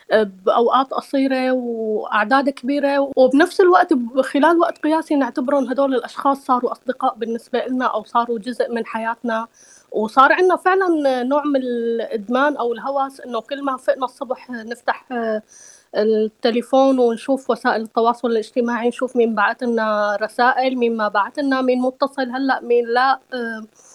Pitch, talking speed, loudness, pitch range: 250 Hz, 135 wpm, -19 LUFS, 230-270 Hz